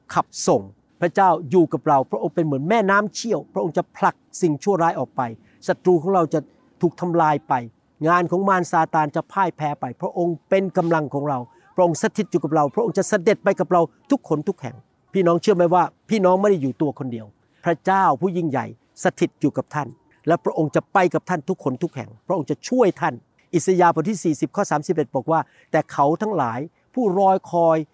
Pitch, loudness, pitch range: 170 Hz, -21 LUFS, 150-190 Hz